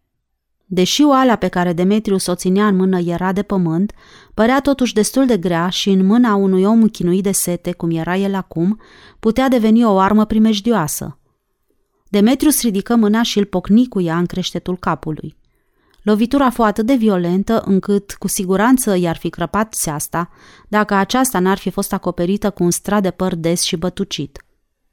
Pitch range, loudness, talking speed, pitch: 180-220 Hz, -16 LUFS, 170 wpm, 195 Hz